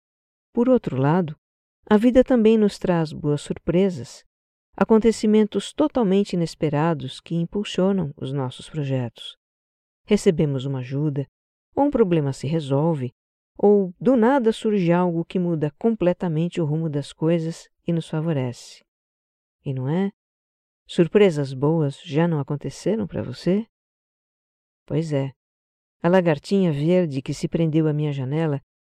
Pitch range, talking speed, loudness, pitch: 140-195 Hz, 130 wpm, -22 LUFS, 165 Hz